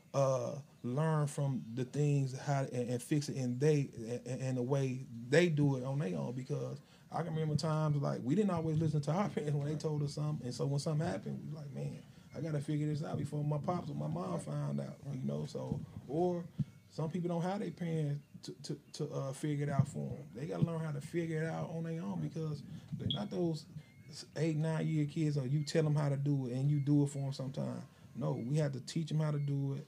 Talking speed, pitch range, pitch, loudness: 250 wpm, 135-160 Hz, 150 Hz, -37 LUFS